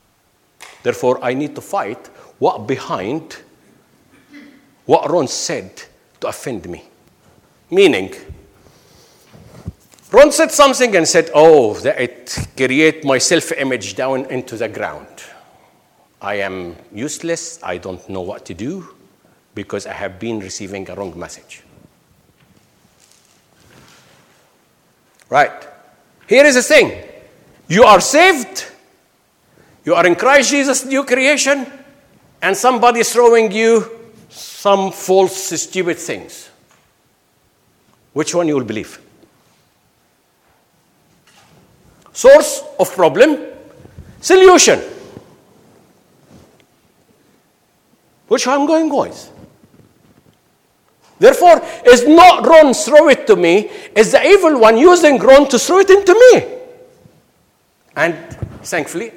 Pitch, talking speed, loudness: 230 Hz, 110 wpm, -12 LUFS